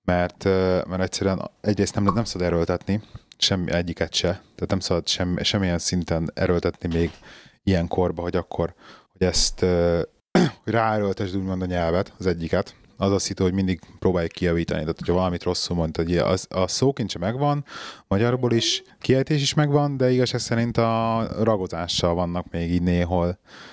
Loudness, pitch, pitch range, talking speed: -23 LUFS, 95 Hz, 85-110 Hz, 165 wpm